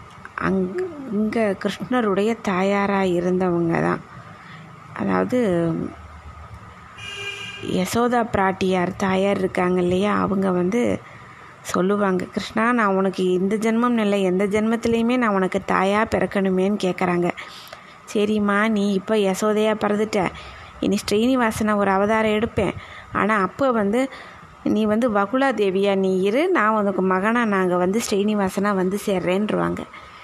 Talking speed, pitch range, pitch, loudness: 110 wpm, 185-215 Hz, 200 Hz, -21 LUFS